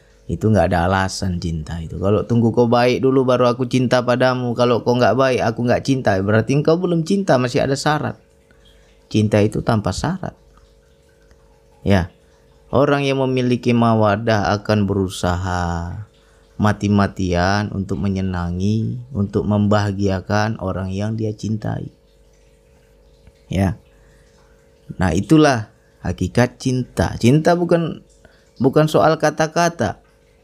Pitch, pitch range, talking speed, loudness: 110 Hz, 95-130 Hz, 115 wpm, -18 LUFS